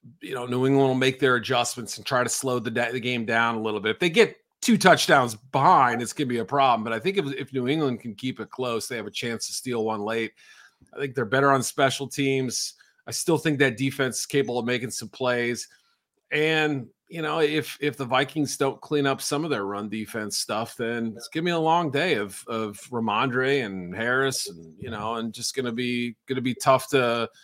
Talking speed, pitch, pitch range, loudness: 245 wpm, 130 Hz, 115-140 Hz, -25 LUFS